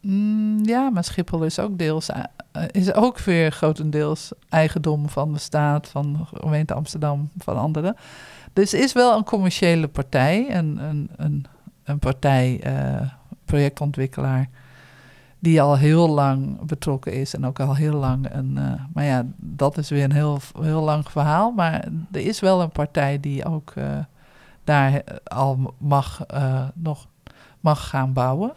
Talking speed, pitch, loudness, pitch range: 155 wpm, 150 Hz, -22 LUFS, 135-165 Hz